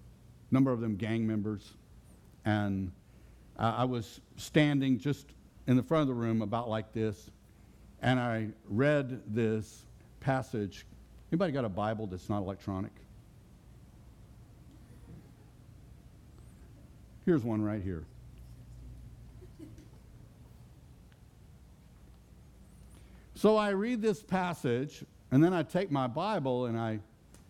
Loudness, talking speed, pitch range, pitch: -32 LUFS, 105 wpm, 105-135 Hz, 115 Hz